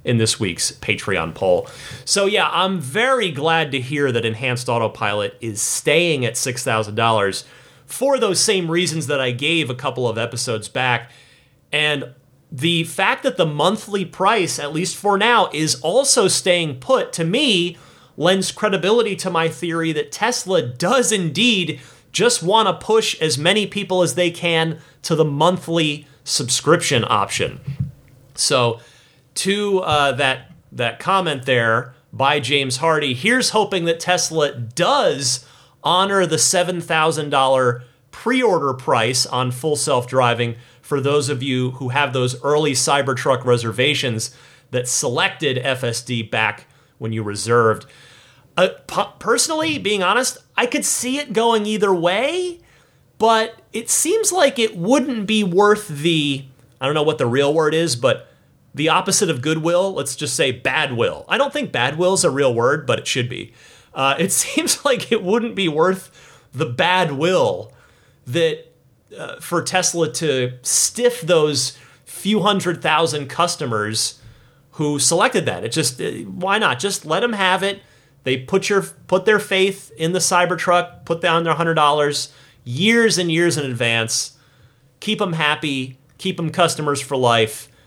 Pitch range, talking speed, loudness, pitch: 130-190 Hz, 155 wpm, -18 LUFS, 155 Hz